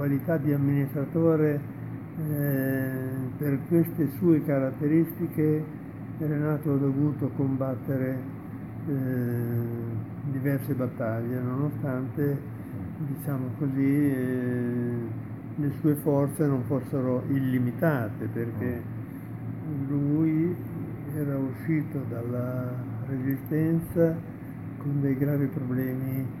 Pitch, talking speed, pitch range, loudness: 135 Hz, 80 wpm, 125-145 Hz, -28 LUFS